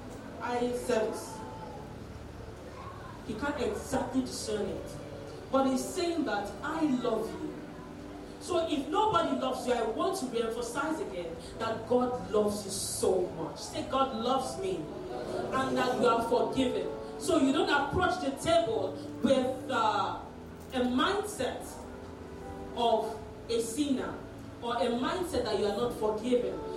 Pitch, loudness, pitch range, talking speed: 255 Hz, -31 LUFS, 235-305 Hz, 135 wpm